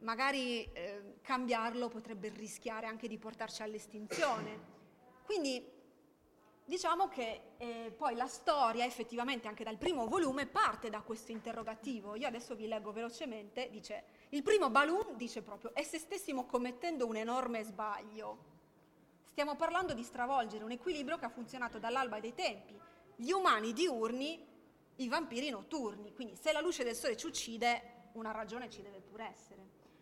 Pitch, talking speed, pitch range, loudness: 235 Hz, 150 wpm, 220-275 Hz, -38 LUFS